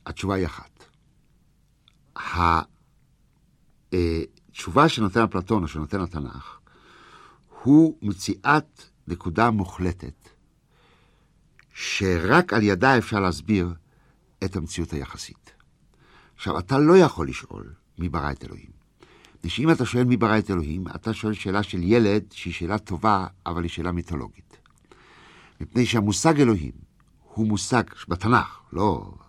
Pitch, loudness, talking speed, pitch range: 100 Hz, -23 LUFS, 115 wpm, 85-115 Hz